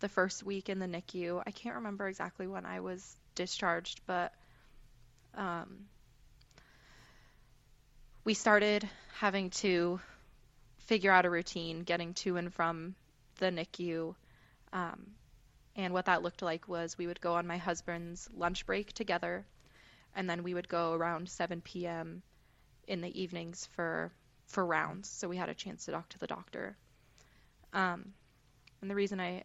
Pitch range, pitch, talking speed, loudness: 135-185 Hz, 170 Hz, 155 wpm, -36 LUFS